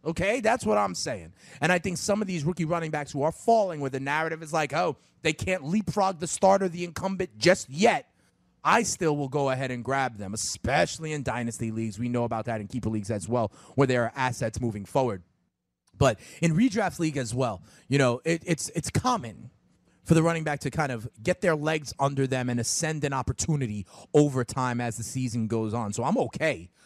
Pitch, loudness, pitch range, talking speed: 140 Hz, -27 LUFS, 120-165 Hz, 215 wpm